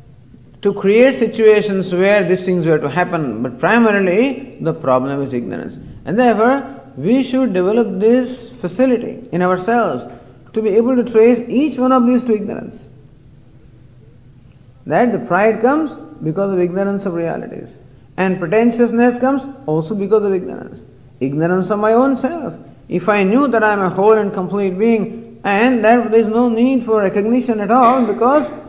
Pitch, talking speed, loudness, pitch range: 210 Hz, 165 wpm, -15 LUFS, 165-235 Hz